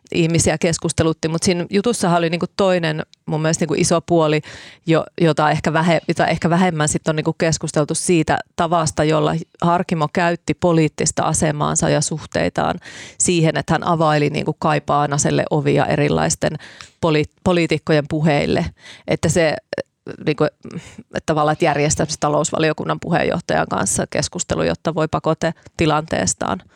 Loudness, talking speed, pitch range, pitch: -18 LUFS, 135 wpm, 155-170 Hz, 160 Hz